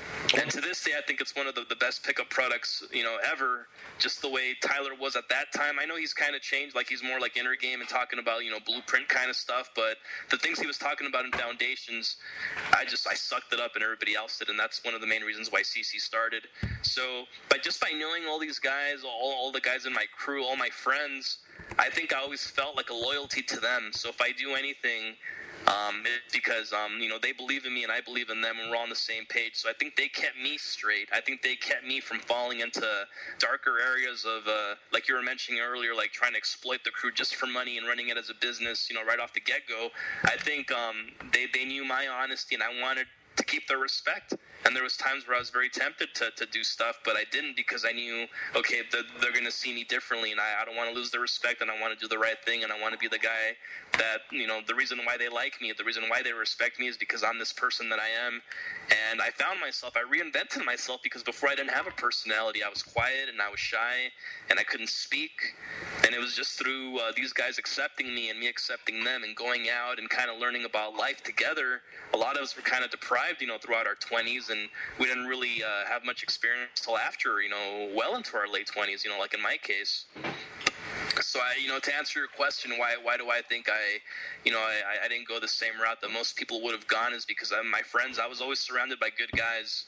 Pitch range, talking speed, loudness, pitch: 115-130 Hz, 260 wpm, -29 LUFS, 120 Hz